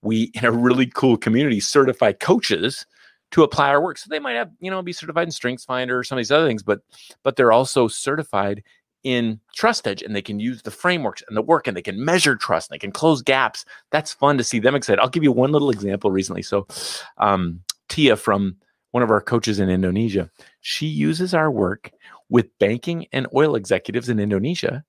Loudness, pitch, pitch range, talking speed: -20 LUFS, 120 Hz, 105-140 Hz, 215 wpm